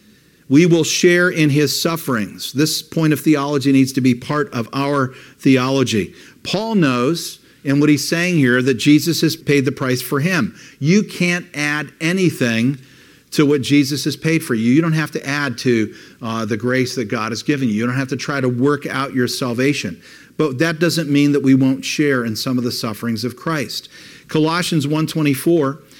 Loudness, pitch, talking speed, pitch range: -17 LUFS, 145 Hz, 195 wpm, 130-155 Hz